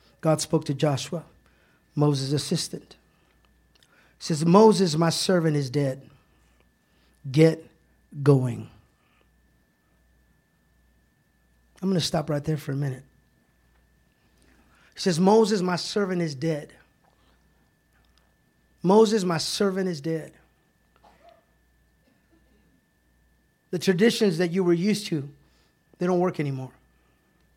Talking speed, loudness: 100 wpm, -24 LUFS